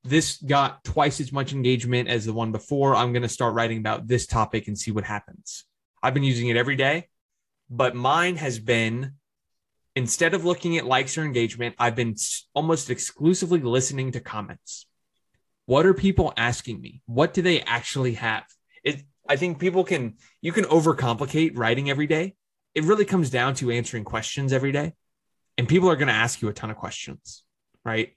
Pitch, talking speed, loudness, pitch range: 130 Hz, 185 wpm, -24 LUFS, 120-155 Hz